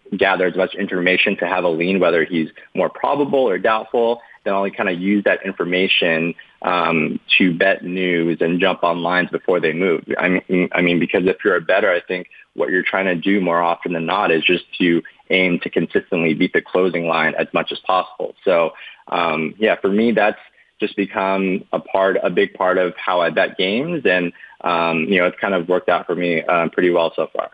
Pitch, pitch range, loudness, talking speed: 90 Hz, 85-95 Hz, -18 LUFS, 220 wpm